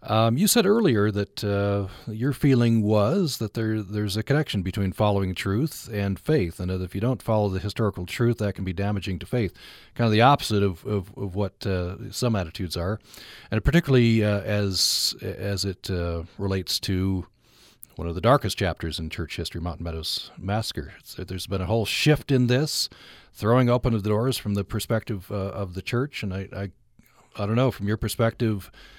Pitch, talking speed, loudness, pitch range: 105 Hz, 195 wpm, -25 LUFS, 95-115 Hz